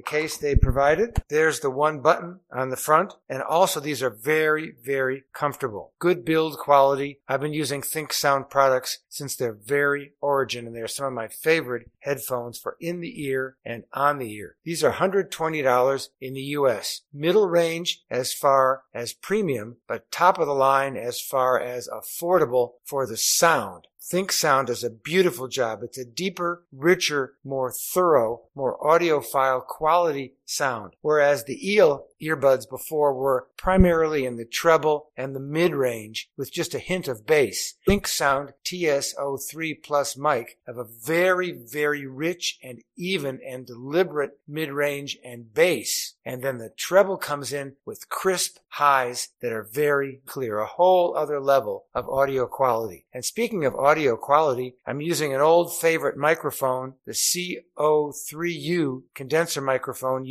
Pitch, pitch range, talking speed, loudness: 140 Hz, 130-160 Hz, 155 wpm, -24 LUFS